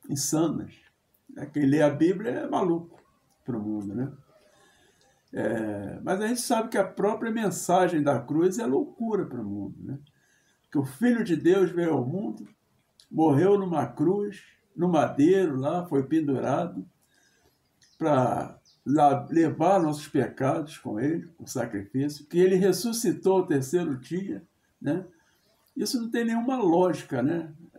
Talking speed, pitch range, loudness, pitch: 145 wpm, 145-200 Hz, -26 LUFS, 170 Hz